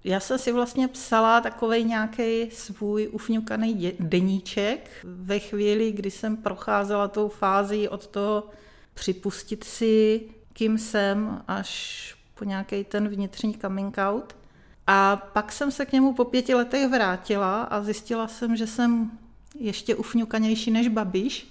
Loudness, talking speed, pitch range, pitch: -25 LUFS, 135 wpm, 200-230 Hz, 215 Hz